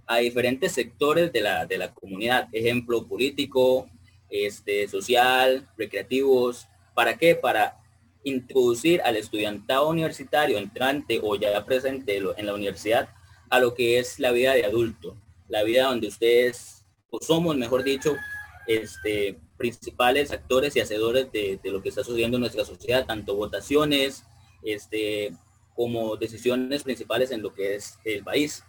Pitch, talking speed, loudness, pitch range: 120 Hz, 145 wpm, -25 LUFS, 105-140 Hz